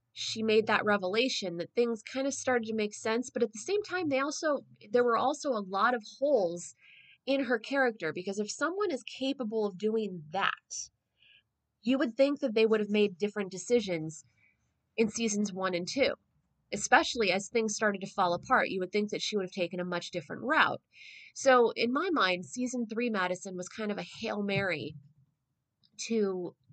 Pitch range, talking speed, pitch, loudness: 185-245 Hz, 190 wpm, 215 Hz, -31 LUFS